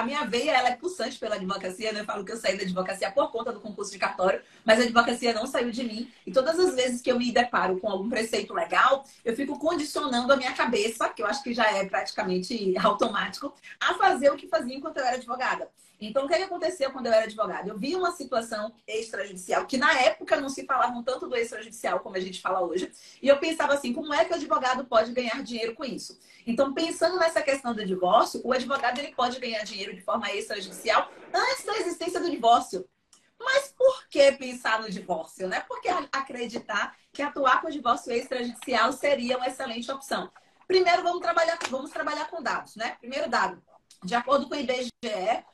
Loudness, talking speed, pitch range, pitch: -27 LUFS, 210 wpm, 220-295 Hz, 255 Hz